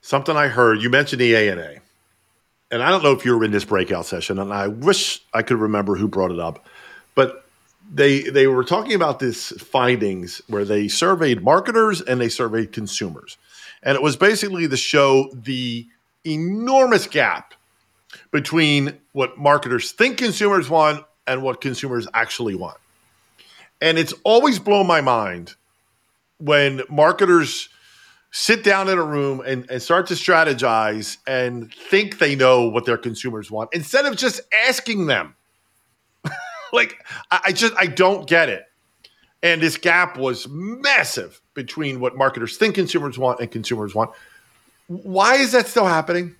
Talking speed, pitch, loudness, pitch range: 160 wpm, 140 Hz, -18 LUFS, 120-180 Hz